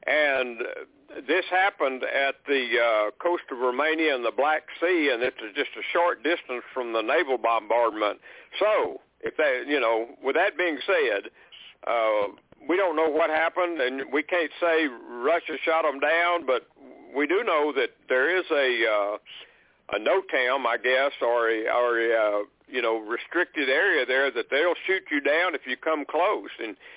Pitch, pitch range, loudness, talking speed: 150 Hz, 120-175 Hz, -25 LUFS, 180 wpm